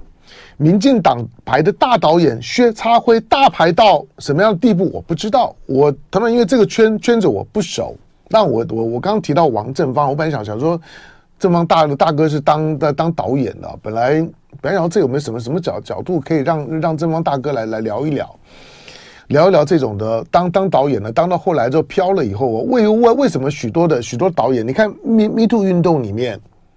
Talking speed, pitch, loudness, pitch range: 315 characters per minute, 160 Hz, -15 LUFS, 135-200 Hz